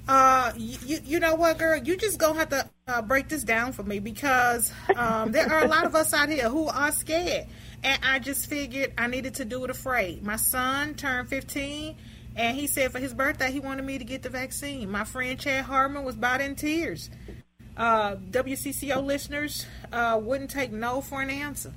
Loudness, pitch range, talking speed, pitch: -26 LUFS, 255-290 Hz, 205 wpm, 270 Hz